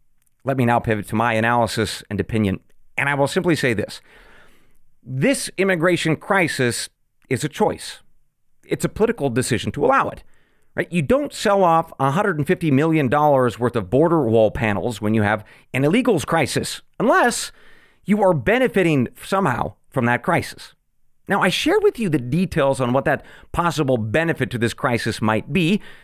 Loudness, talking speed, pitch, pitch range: -20 LUFS, 165 wpm, 135 Hz, 120-175 Hz